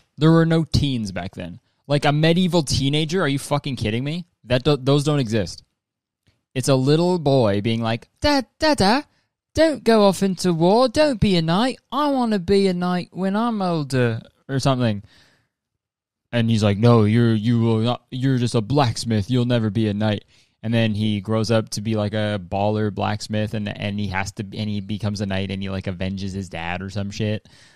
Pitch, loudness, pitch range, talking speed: 120 Hz, -21 LUFS, 105-160 Hz, 205 wpm